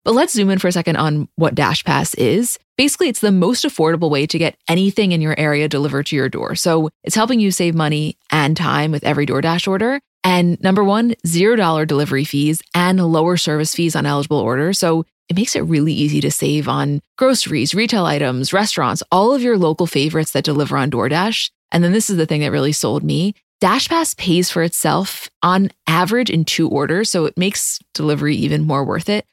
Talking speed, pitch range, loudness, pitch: 215 wpm, 150-195 Hz, -16 LUFS, 165 Hz